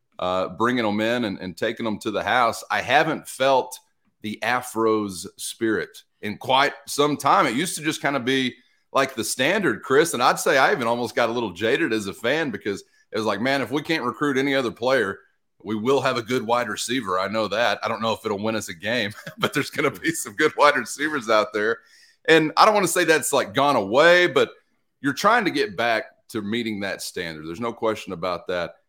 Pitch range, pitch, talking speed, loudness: 110-155 Hz, 120 Hz, 235 wpm, -22 LUFS